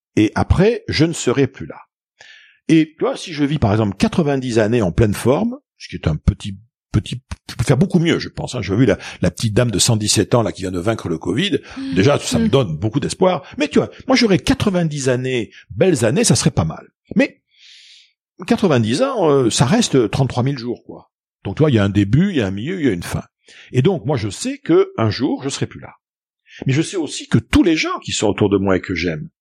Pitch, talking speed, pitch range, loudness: 130 Hz, 250 wpm, 105-165 Hz, -17 LUFS